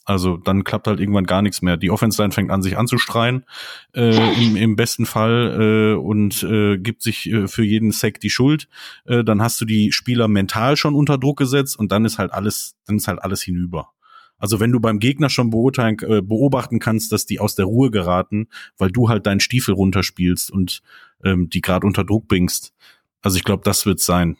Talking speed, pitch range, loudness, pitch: 210 wpm, 100-115 Hz, -18 LUFS, 110 Hz